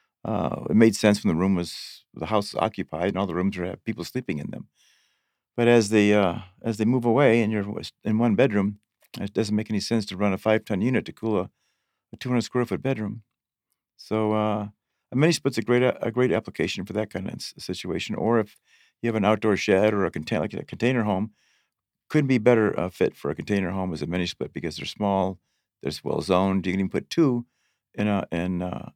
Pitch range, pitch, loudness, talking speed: 95-115 Hz, 105 Hz, -25 LUFS, 215 wpm